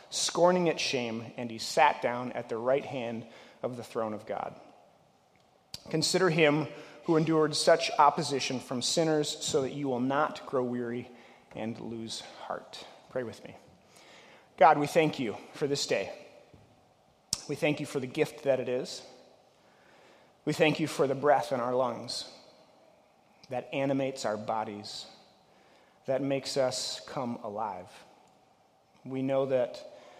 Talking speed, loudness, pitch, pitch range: 145 wpm, -30 LUFS, 135 Hz, 120-150 Hz